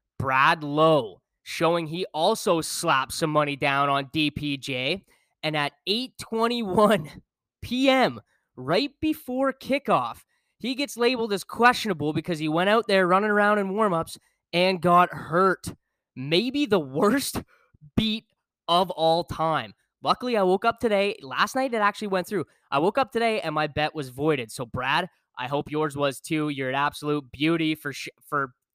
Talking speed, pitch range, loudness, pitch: 160 wpm, 150-210 Hz, -24 LUFS, 170 Hz